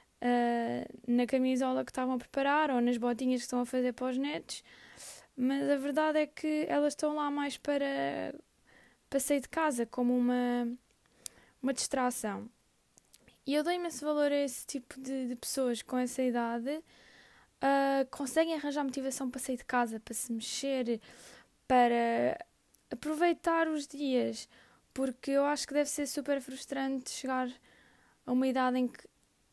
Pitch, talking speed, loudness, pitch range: 265 Hz, 160 wpm, -32 LUFS, 245-285 Hz